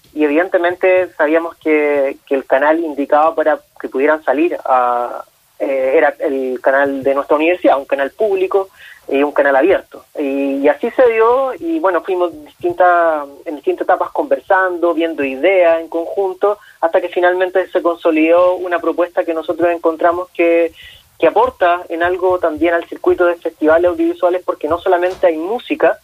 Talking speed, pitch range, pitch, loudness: 160 wpm, 155-185 Hz, 170 Hz, -15 LUFS